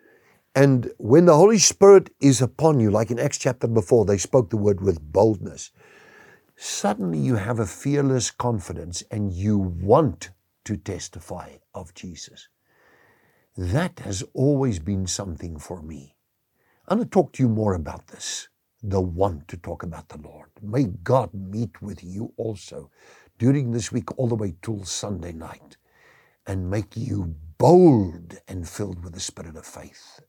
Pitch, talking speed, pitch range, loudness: 105 Hz, 160 wpm, 90-125 Hz, -21 LUFS